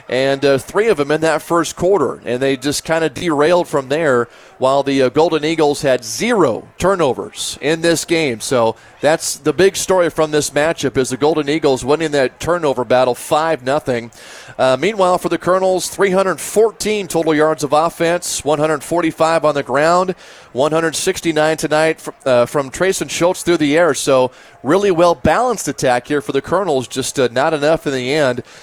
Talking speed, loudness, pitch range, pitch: 180 wpm, -16 LUFS, 135-170 Hz, 155 Hz